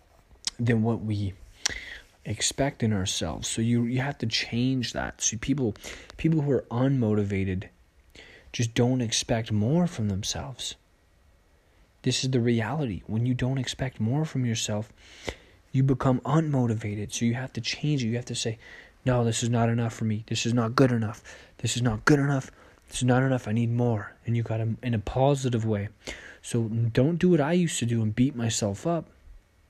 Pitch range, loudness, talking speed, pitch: 105-130 Hz, -27 LUFS, 190 wpm, 115 Hz